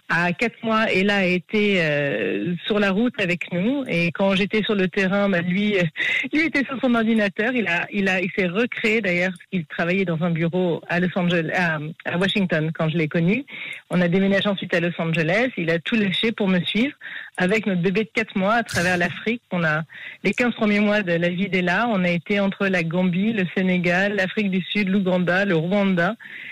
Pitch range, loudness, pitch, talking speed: 175-210 Hz, -21 LUFS, 190 Hz, 215 wpm